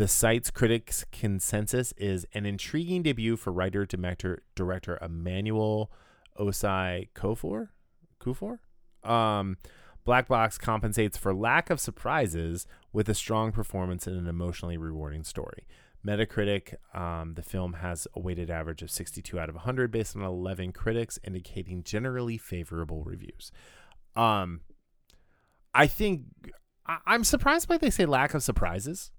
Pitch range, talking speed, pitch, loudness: 90-115 Hz, 140 wpm, 100 Hz, -30 LUFS